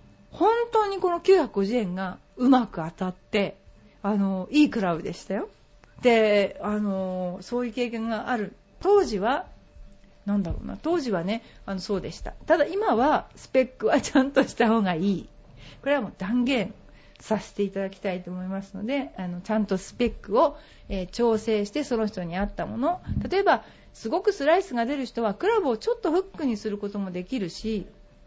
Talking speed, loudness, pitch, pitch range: 315 characters per minute, -26 LUFS, 220 Hz, 195-275 Hz